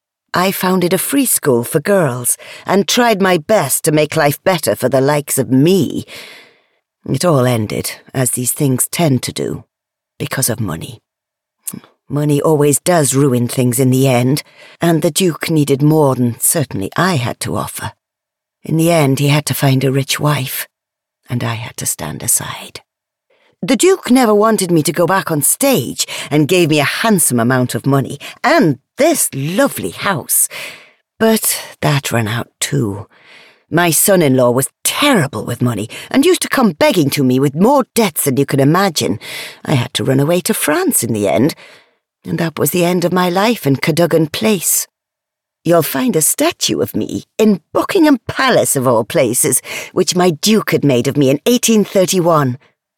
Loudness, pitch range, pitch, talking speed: -14 LUFS, 135-190 Hz, 155 Hz, 180 wpm